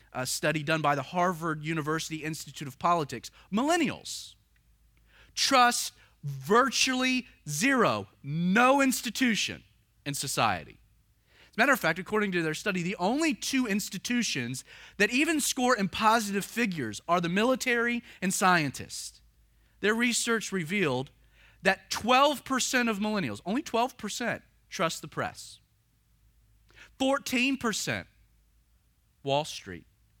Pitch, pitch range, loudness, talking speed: 190 Hz, 145-240 Hz, -28 LUFS, 115 wpm